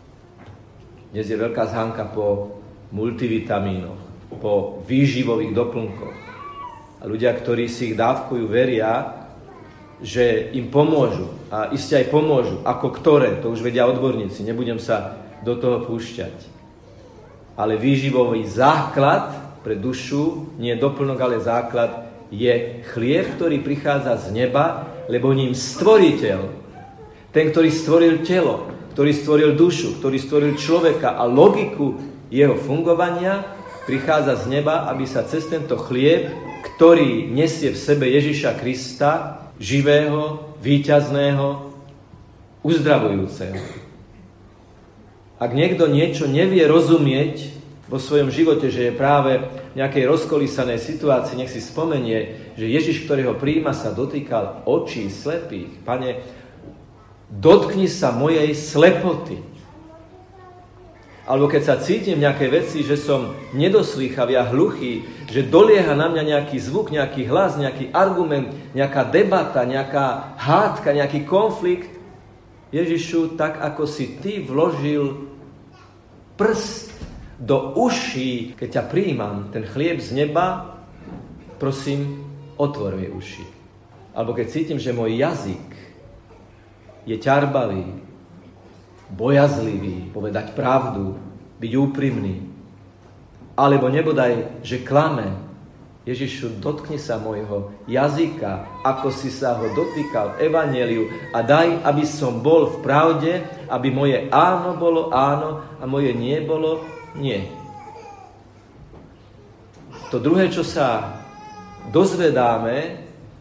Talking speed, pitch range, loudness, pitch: 115 wpm, 115-150 Hz, -20 LUFS, 135 Hz